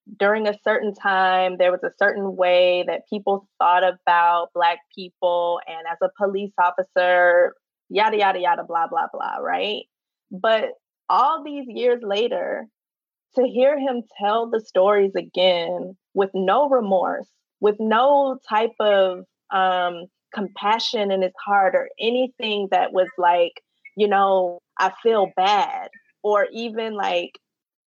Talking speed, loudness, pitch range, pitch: 140 wpm, -21 LUFS, 180-230 Hz, 200 Hz